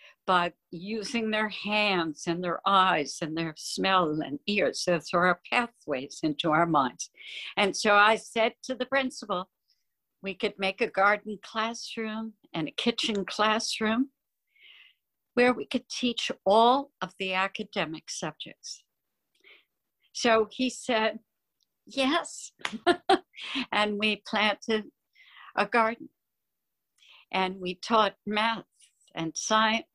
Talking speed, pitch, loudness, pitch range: 120 wpm, 215 Hz, -27 LUFS, 185-235 Hz